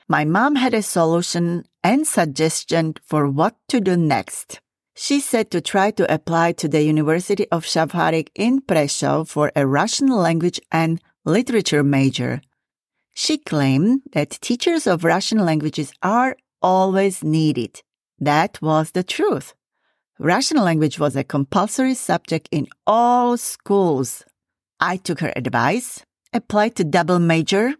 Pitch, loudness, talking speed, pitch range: 175 Hz, -19 LUFS, 135 wpm, 155-220 Hz